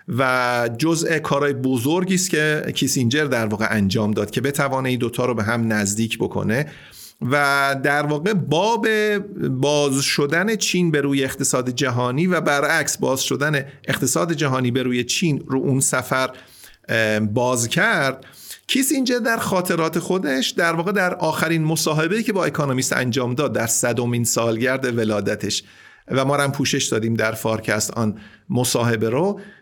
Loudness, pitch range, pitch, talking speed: -20 LUFS, 120-160 Hz, 135 Hz, 150 wpm